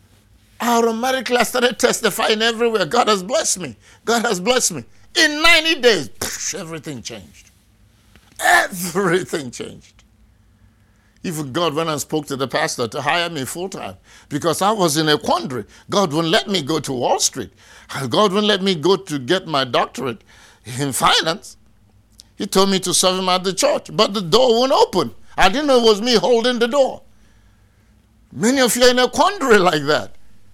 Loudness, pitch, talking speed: -17 LUFS, 175 Hz, 180 wpm